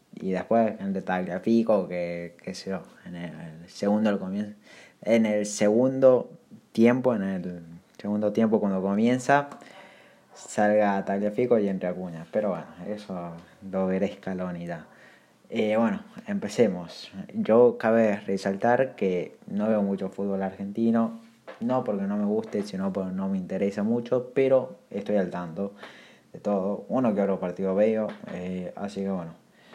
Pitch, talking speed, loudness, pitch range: 100 Hz, 145 wpm, -26 LUFS, 95-115 Hz